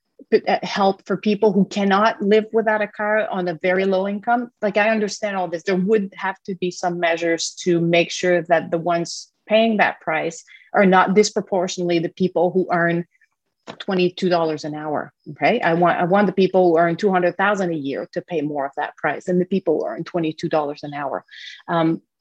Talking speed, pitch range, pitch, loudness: 205 wpm, 170-205 Hz, 185 Hz, -20 LUFS